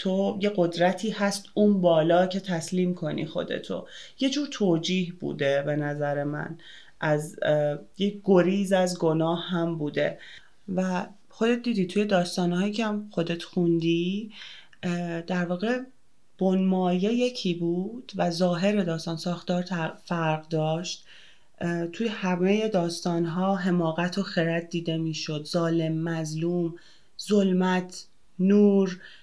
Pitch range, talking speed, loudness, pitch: 165-195 Hz, 115 wpm, -26 LUFS, 180 Hz